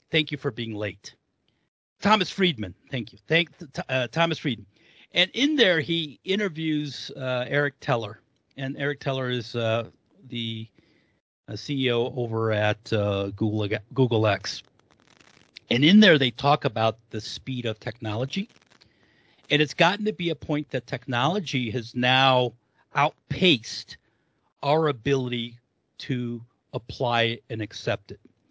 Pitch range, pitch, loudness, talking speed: 115-150 Hz, 130 Hz, -25 LUFS, 135 wpm